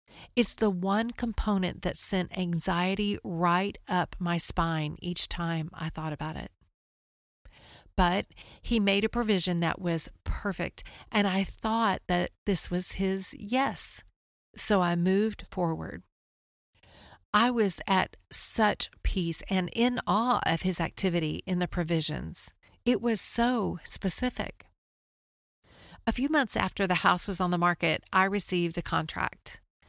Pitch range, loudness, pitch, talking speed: 170-210 Hz, -28 LUFS, 185 Hz, 140 wpm